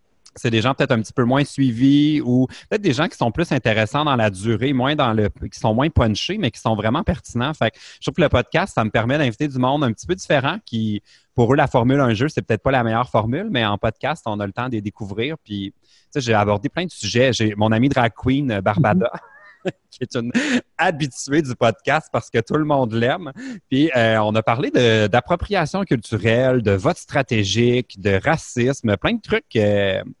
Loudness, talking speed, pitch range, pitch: -19 LUFS, 225 wpm, 110-140 Hz, 120 Hz